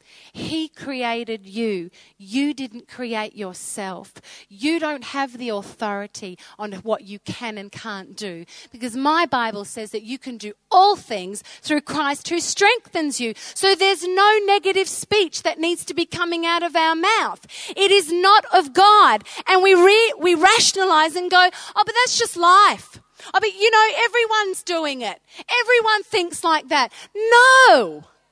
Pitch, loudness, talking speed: 330 Hz, -17 LUFS, 165 wpm